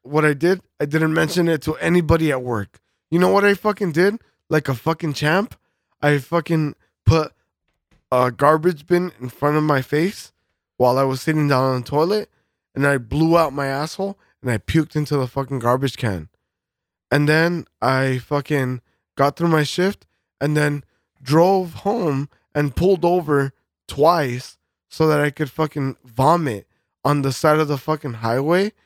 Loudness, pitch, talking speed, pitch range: -20 LUFS, 150 Hz, 175 wpm, 135-165 Hz